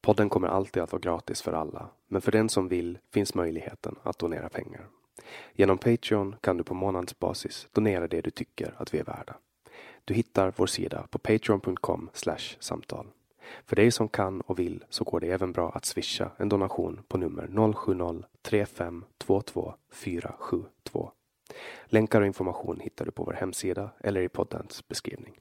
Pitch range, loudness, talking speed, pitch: 90-110 Hz, -30 LUFS, 170 wpm, 100 Hz